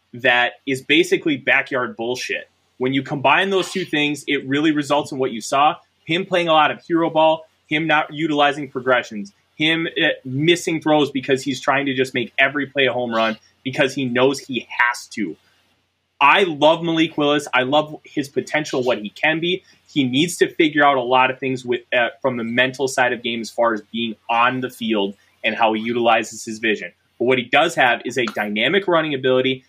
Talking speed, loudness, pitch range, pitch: 205 wpm, -19 LUFS, 120-150 Hz, 135 Hz